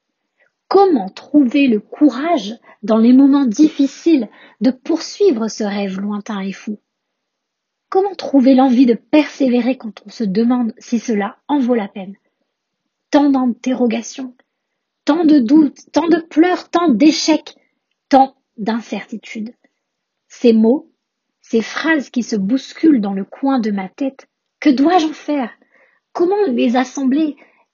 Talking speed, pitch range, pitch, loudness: 135 wpm, 230-295 Hz, 265 Hz, -15 LUFS